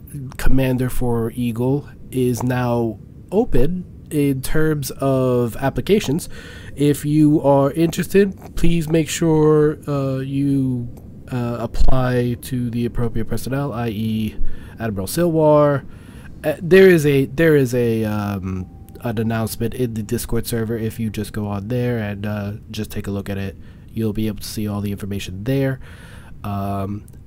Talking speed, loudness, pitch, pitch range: 145 wpm, -20 LUFS, 120 Hz, 110-140 Hz